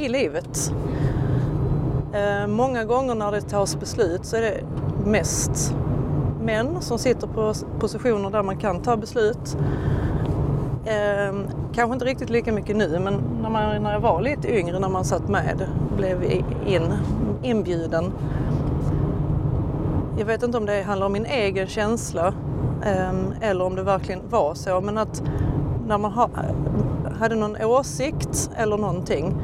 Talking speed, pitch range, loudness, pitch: 150 wpm, 145-220 Hz, -24 LUFS, 200 Hz